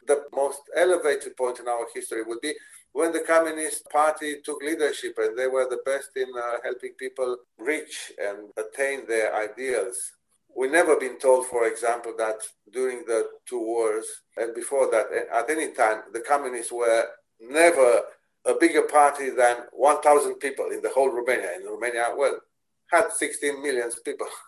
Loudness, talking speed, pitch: -25 LUFS, 165 wpm, 165 Hz